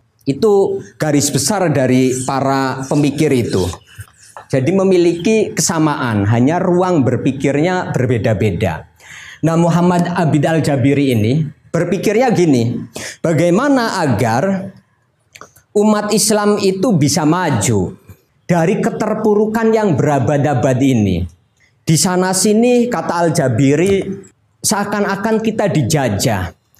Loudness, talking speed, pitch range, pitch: -14 LUFS, 90 wpm, 130-195 Hz, 155 Hz